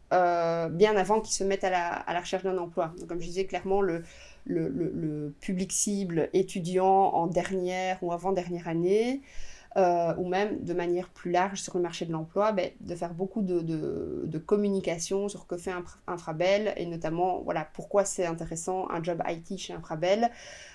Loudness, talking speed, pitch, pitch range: -29 LUFS, 190 wpm, 180 Hz, 170-195 Hz